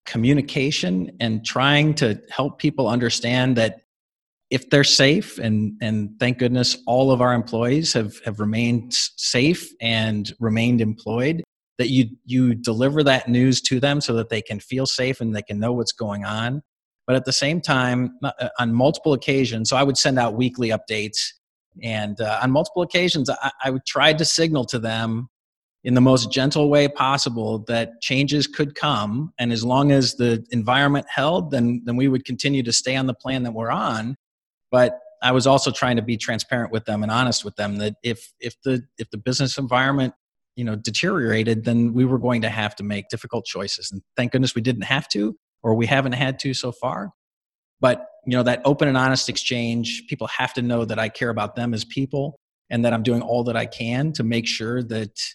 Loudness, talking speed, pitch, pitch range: -21 LUFS, 200 wpm, 125 Hz, 115-135 Hz